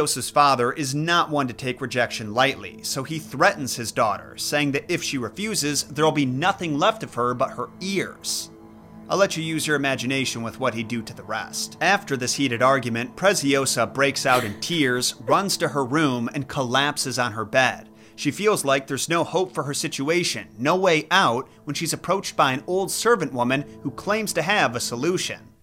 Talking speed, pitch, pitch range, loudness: 200 wpm, 140 Hz, 125-160 Hz, -23 LUFS